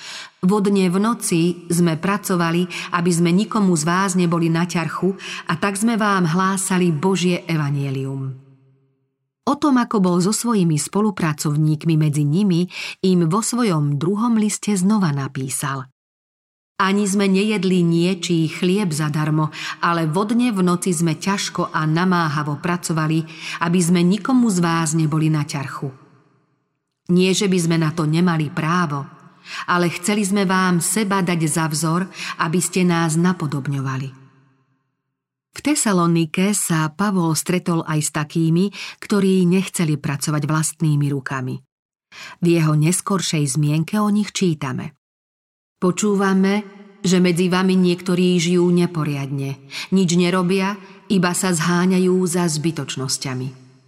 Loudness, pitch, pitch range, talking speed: -19 LUFS, 175 Hz, 155-190 Hz, 130 wpm